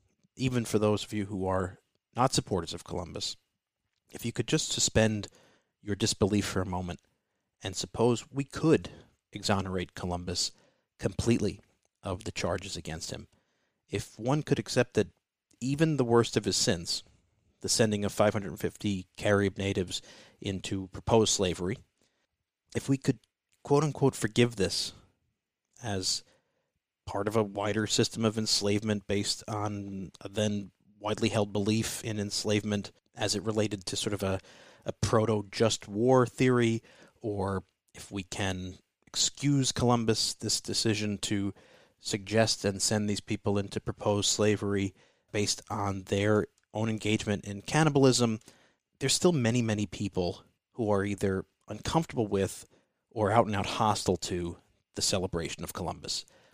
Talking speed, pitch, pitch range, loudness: 140 wpm, 105 Hz, 100-115 Hz, -30 LUFS